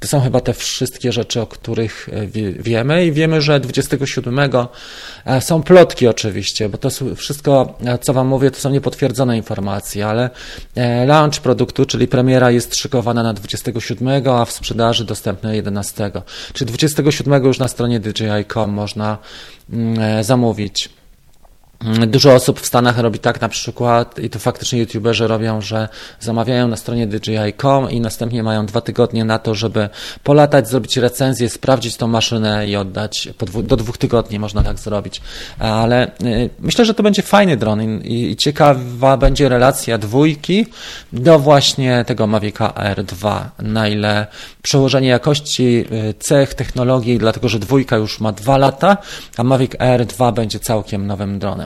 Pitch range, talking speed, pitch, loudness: 110-135 Hz, 145 wpm, 120 Hz, -15 LUFS